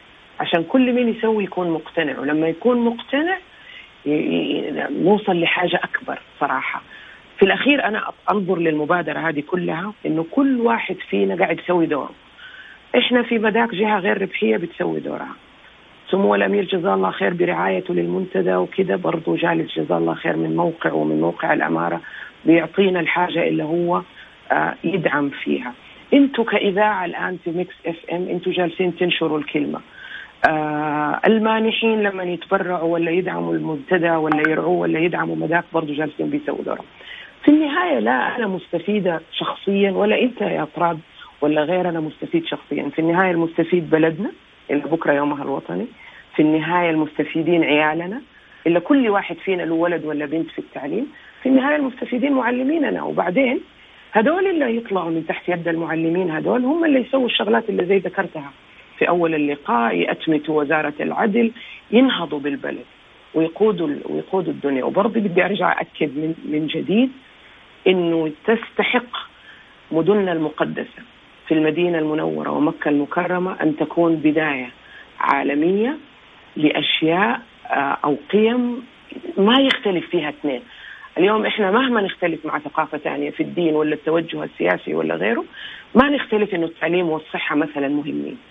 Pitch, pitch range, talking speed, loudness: 175 Hz, 155-215 Hz, 140 wpm, -20 LUFS